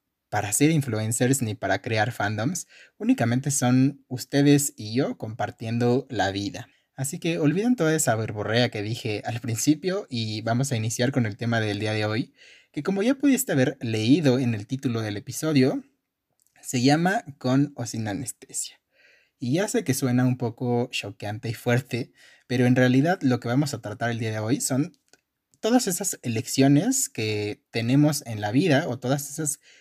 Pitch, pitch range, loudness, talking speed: 125 Hz, 115-145 Hz, -25 LUFS, 175 wpm